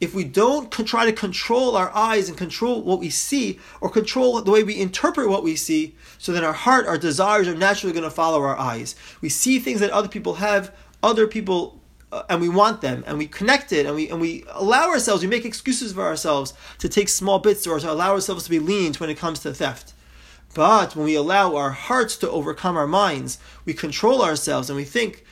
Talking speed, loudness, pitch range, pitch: 230 wpm, -21 LUFS, 160-220 Hz, 195 Hz